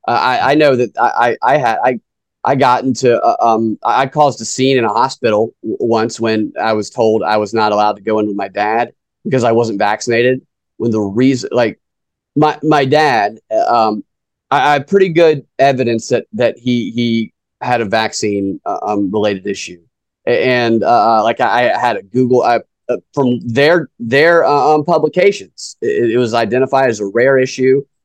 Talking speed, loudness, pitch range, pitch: 195 wpm, -13 LUFS, 110-140 Hz, 120 Hz